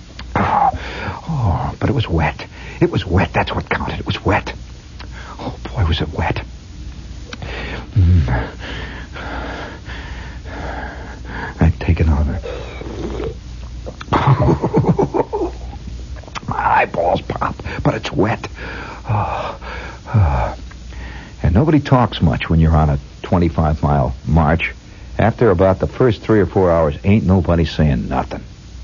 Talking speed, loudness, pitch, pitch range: 110 wpm, -18 LUFS, 80 Hz, 70-90 Hz